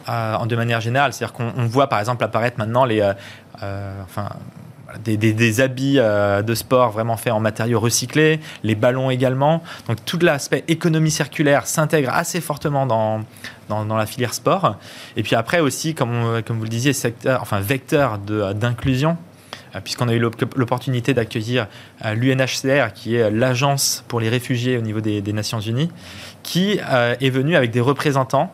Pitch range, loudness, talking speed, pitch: 110-140 Hz, -19 LUFS, 175 wpm, 125 Hz